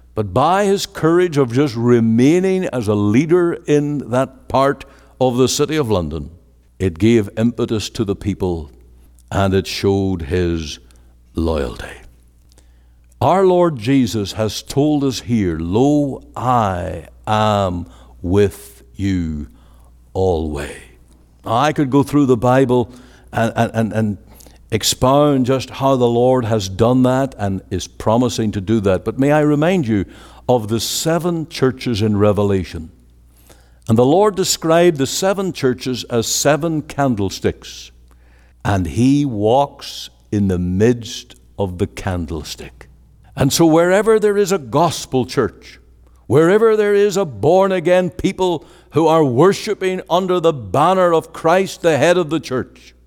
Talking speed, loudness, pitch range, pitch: 140 wpm, -16 LUFS, 90-145 Hz, 115 Hz